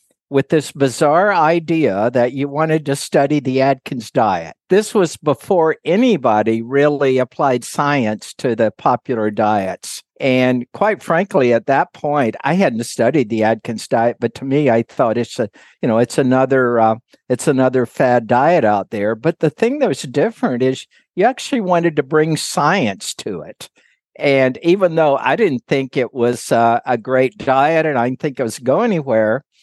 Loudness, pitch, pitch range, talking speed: -16 LUFS, 135 Hz, 120-155 Hz, 180 wpm